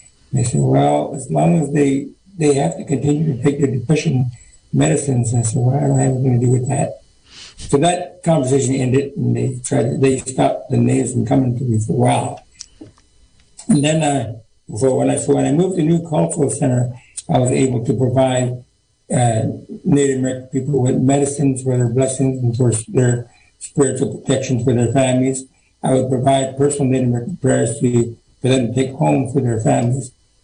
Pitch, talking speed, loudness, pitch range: 130 Hz, 195 wpm, -17 LUFS, 120-140 Hz